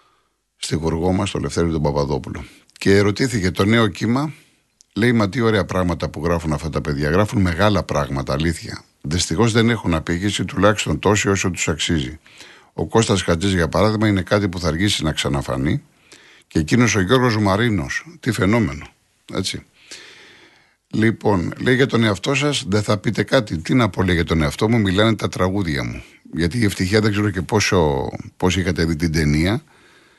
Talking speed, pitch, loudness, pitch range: 175 wpm, 95 Hz, -19 LUFS, 85-110 Hz